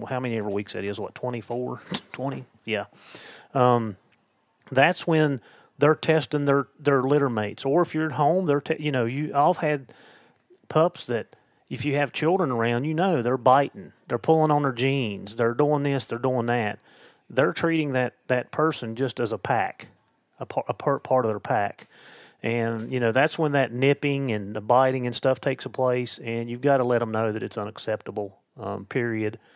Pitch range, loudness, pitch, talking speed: 115-145 Hz, -25 LUFS, 130 Hz, 195 wpm